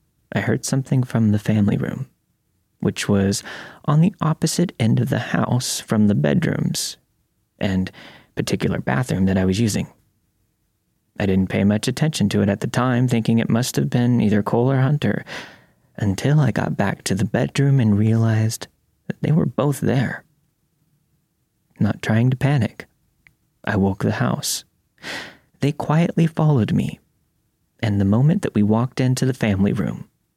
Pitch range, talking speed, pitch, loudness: 105-145 Hz, 160 wpm, 120 Hz, -20 LUFS